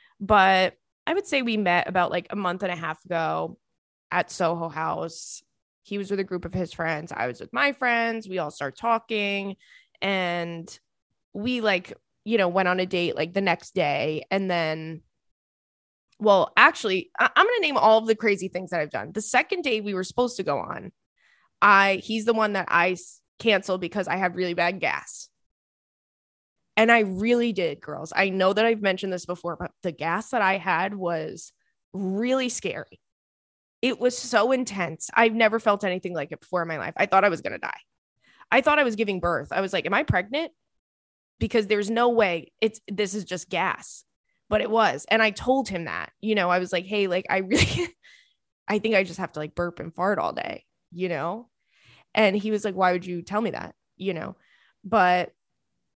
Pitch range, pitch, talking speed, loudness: 175-225 Hz, 195 Hz, 205 wpm, -24 LUFS